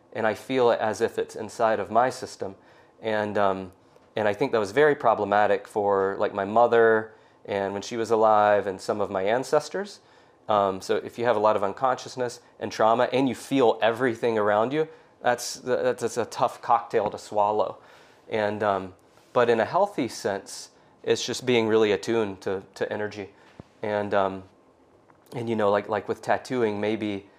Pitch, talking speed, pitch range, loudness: 105 Hz, 180 wpm, 100-120 Hz, -25 LUFS